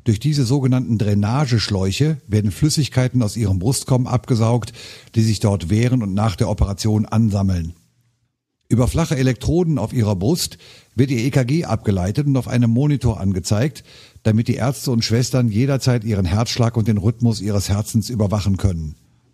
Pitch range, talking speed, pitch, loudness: 105-130 Hz, 150 wpm, 115 Hz, -19 LUFS